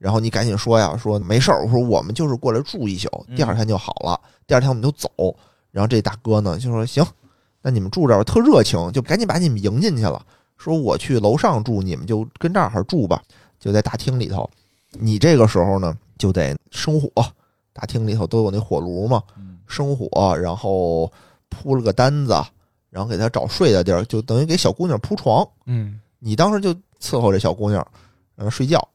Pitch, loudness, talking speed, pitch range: 110 Hz, -19 LUFS, 305 characters per minute, 100-130 Hz